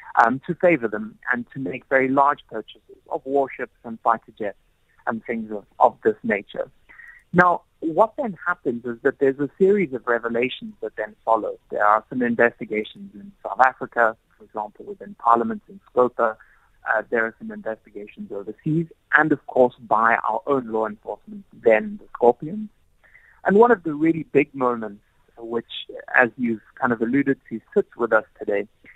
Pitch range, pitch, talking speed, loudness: 115-175 Hz, 130 Hz, 170 wpm, -22 LUFS